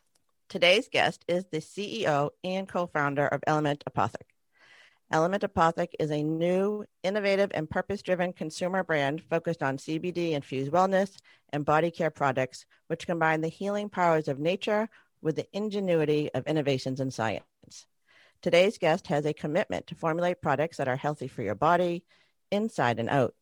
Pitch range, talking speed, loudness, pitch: 145-180 Hz, 150 wpm, -28 LUFS, 160 Hz